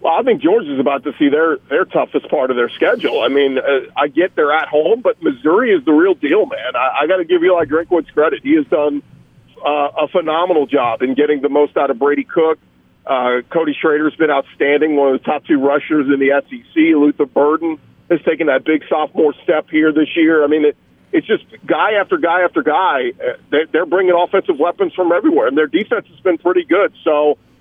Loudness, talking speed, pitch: -15 LUFS, 220 wpm, 160 Hz